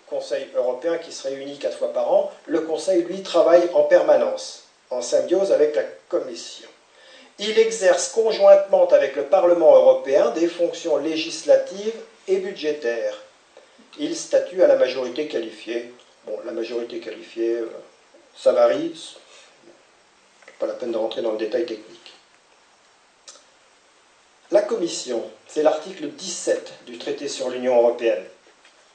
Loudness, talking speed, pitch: -21 LUFS, 130 wpm, 205 Hz